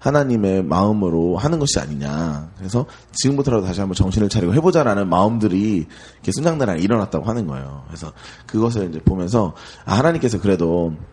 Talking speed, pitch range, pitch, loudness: 415 characters per minute, 85-115 Hz, 100 Hz, -19 LUFS